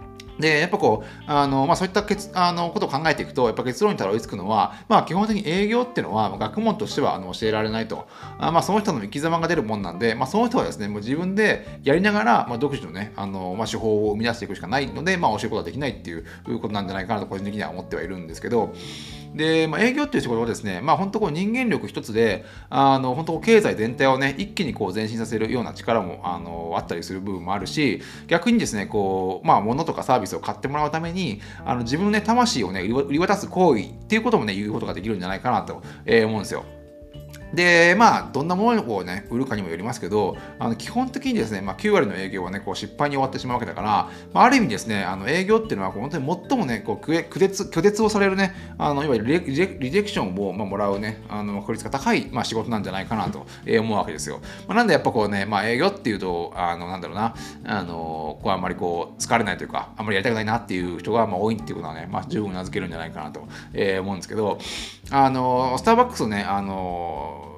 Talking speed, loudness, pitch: 490 characters per minute, -23 LUFS, 115 Hz